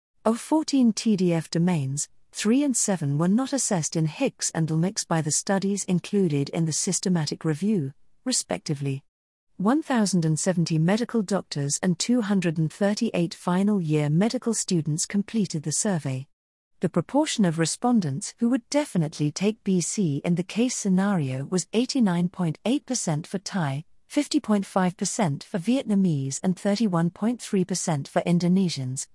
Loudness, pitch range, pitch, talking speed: -25 LUFS, 160-215 Hz, 185 Hz, 120 wpm